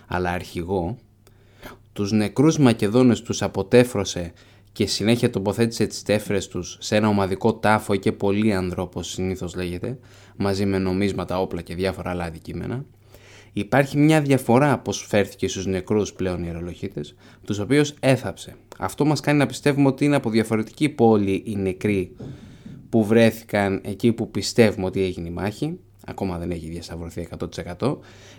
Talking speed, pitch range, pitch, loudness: 145 wpm, 95-115 Hz, 100 Hz, -22 LUFS